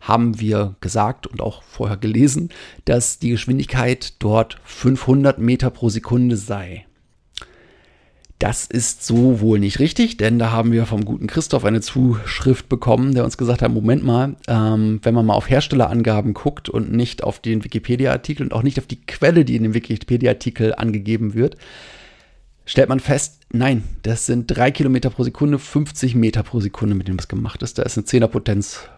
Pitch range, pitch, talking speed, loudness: 110-130 Hz, 120 Hz, 175 wpm, -18 LUFS